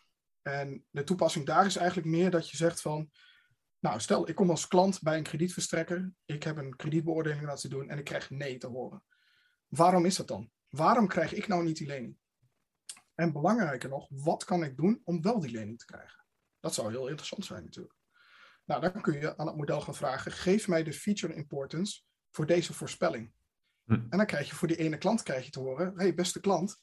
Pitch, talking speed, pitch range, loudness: 165 Hz, 210 wpm, 145-180 Hz, -31 LUFS